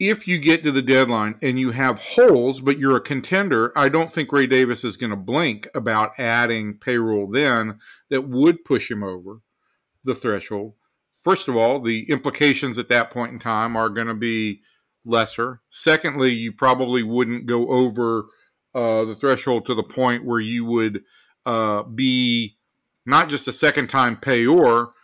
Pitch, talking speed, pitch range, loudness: 120 Hz, 175 wpm, 115-135 Hz, -20 LUFS